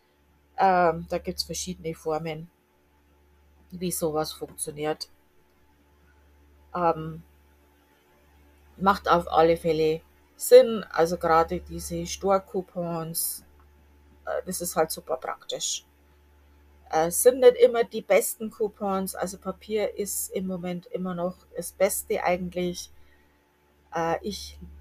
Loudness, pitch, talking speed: -26 LUFS, 160 Hz, 110 wpm